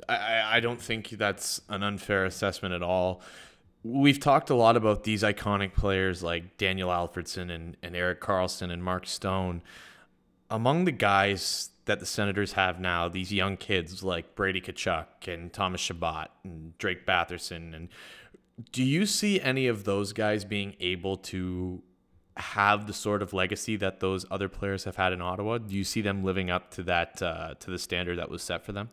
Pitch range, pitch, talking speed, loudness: 90-105 Hz, 95 Hz, 185 wpm, -29 LUFS